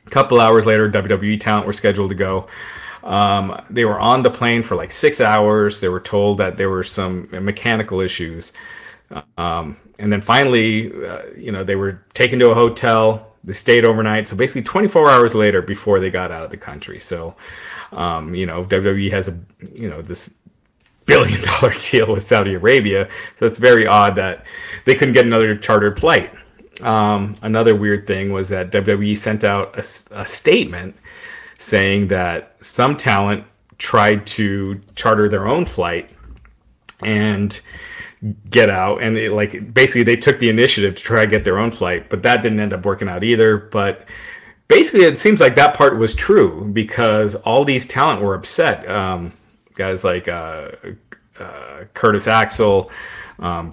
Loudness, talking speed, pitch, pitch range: -15 LUFS, 175 wpm, 105 Hz, 100-115 Hz